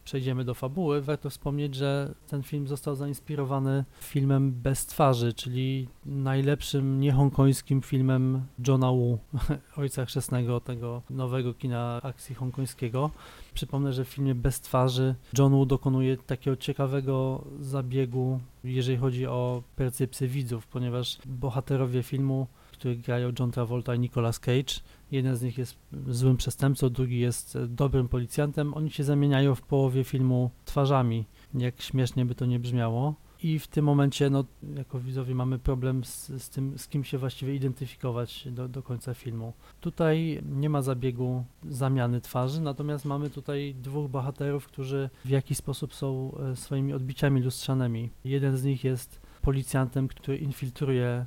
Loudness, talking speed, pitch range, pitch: -29 LUFS, 145 wpm, 125-140 Hz, 135 Hz